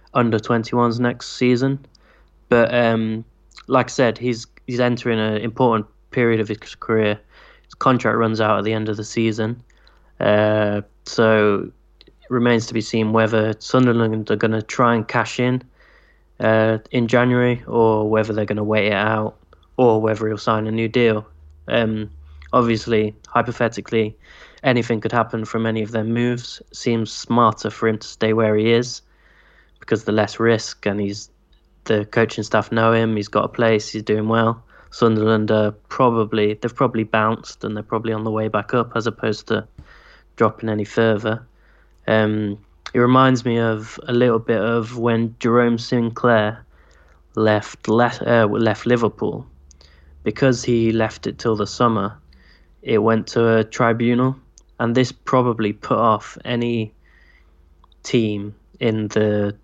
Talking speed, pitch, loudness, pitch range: 160 wpm, 110 Hz, -19 LUFS, 105-120 Hz